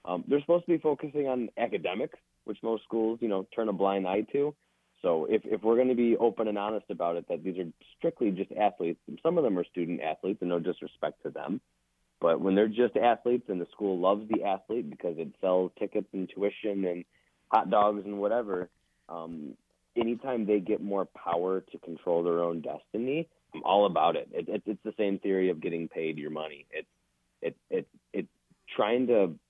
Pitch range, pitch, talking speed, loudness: 90-115 Hz, 100 Hz, 210 wpm, -30 LUFS